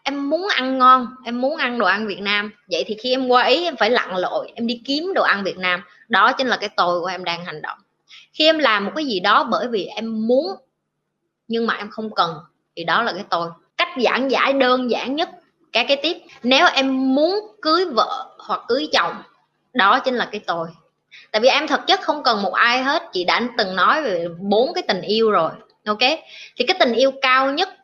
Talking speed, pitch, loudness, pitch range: 235 wpm, 255 Hz, -19 LUFS, 215-300 Hz